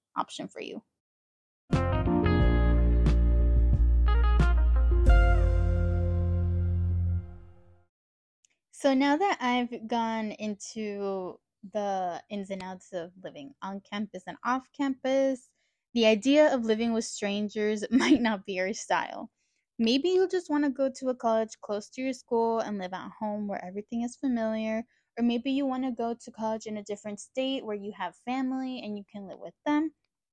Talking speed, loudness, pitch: 145 wpm, -29 LUFS, 210 Hz